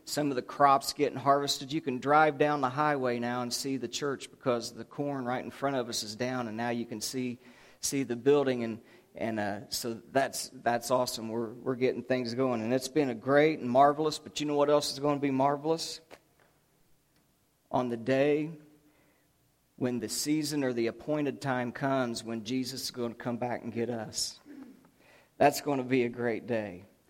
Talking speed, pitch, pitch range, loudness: 205 wpm, 130 Hz, 120-145 Hz, -30 LUFS